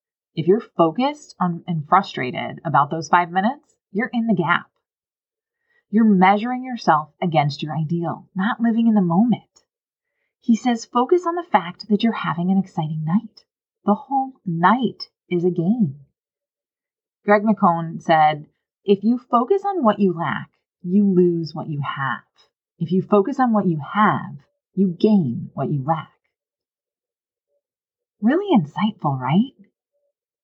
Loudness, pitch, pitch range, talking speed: -20 LUFS, 205 Hz, 175-255 Hz, 145 wpm